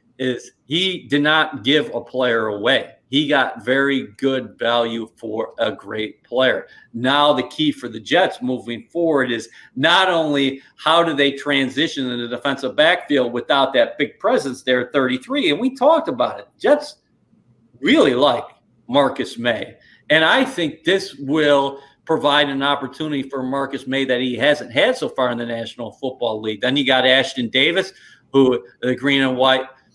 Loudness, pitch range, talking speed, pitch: -18 LUFS, 125-145 Hz, 170 wpm, 135 Hz